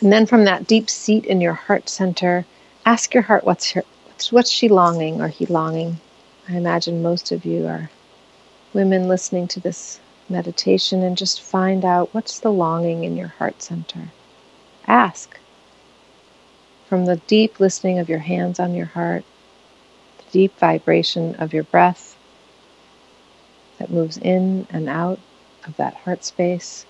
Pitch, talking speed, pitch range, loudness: 180 Hz, 155 wpm, 165-190 Hz, -19 LUFS